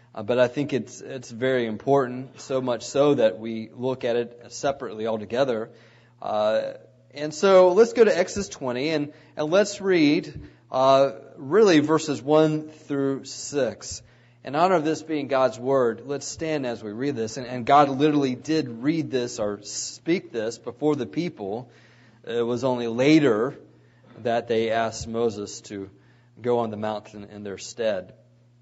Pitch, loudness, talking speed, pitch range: 130 Hz, -24 LUFS, 165 wpm, 115-150 Hz